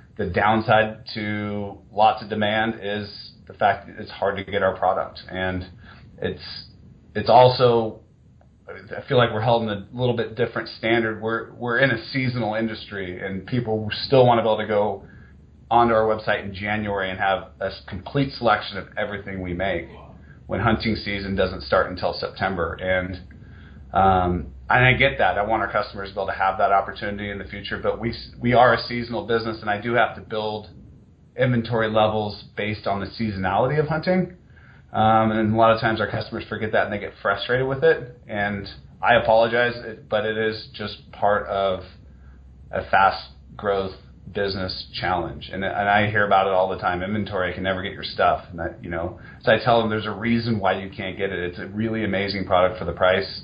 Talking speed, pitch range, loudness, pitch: 200 wpm, 95-115 Hz, -22 LUFS, 105 Hz